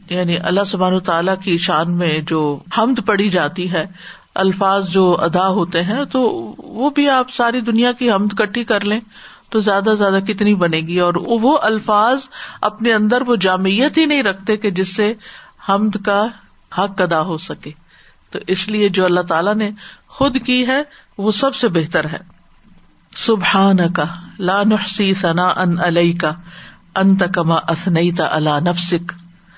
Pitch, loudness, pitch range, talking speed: 195 Hz, -16 LUFS, 175-215 Hz, 165 wpm